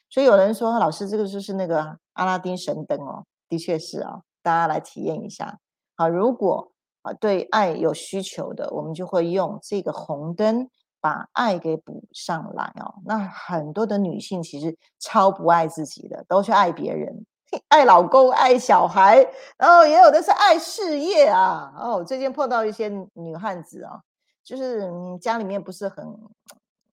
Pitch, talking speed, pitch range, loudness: 200 Hz, 250 characters per minute, 175-245 Hz, -20 LUFS